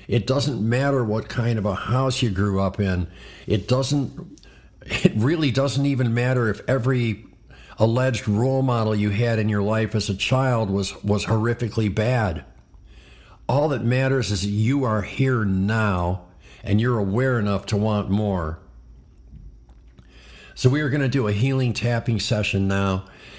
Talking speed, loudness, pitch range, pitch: 160 wpm, -22 LUFS, 95-125 Hz, 110 Hz